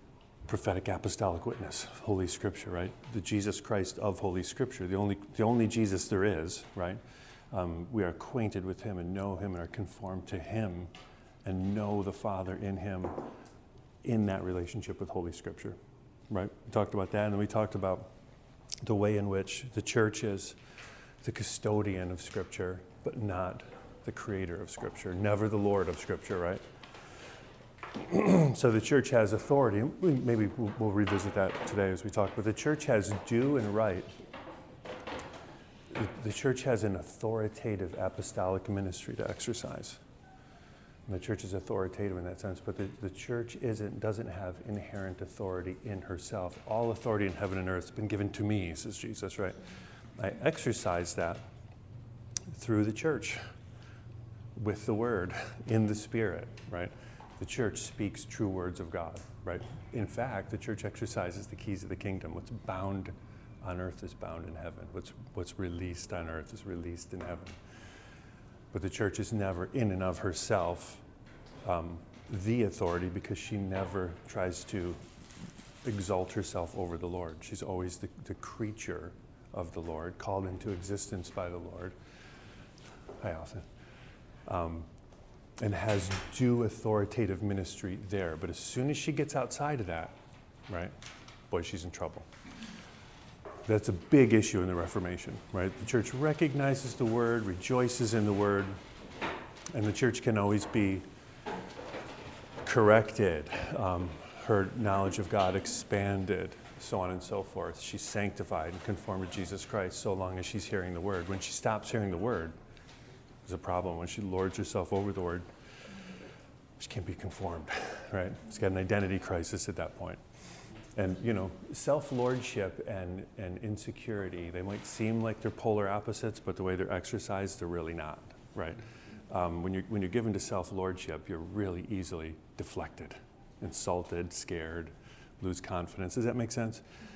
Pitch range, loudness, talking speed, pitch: 90-110 Hz, -34 LUFS, 160 wpm, 100 Hz